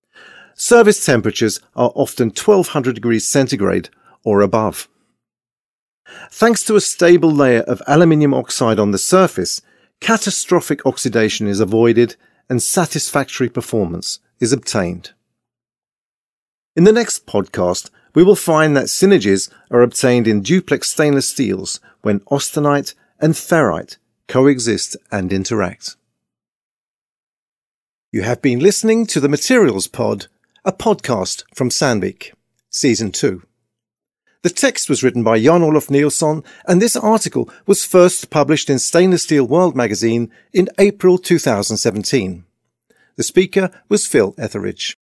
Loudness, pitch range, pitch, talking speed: -15 LUFS, 115-180 Hz, 140 Hz, 125 wpm